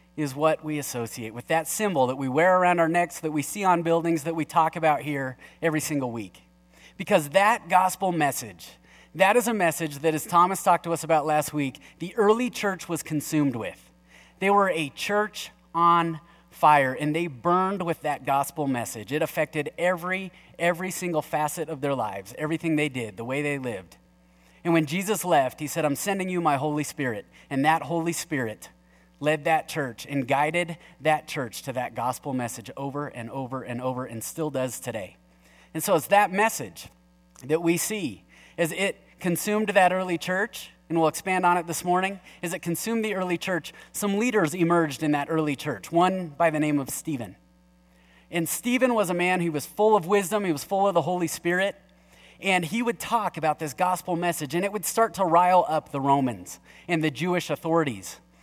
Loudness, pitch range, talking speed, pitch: -25 LUFS, 140-180 Hz, 195 wpm, 160 Hz